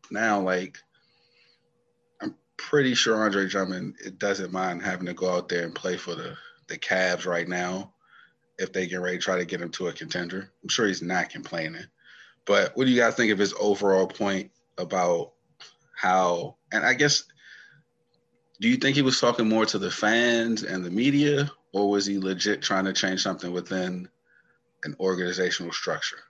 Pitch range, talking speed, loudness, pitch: 90-110 Hz, 185 wpm, -25 LUFS, 95 Hz